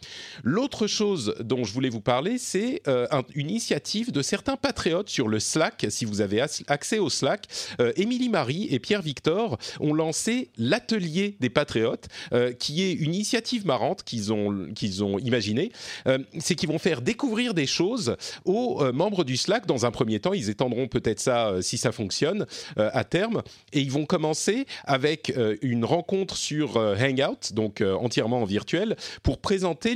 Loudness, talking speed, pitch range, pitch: -26 LUFS, 160 wpm, 120-195 Hz, 140 Hz